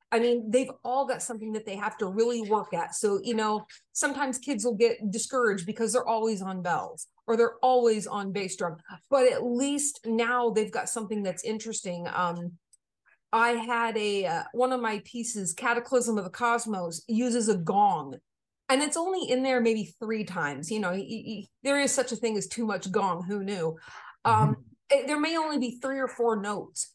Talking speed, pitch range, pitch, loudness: 200 wpm, 205-250 Hz, 225 Hz, -28 LUFS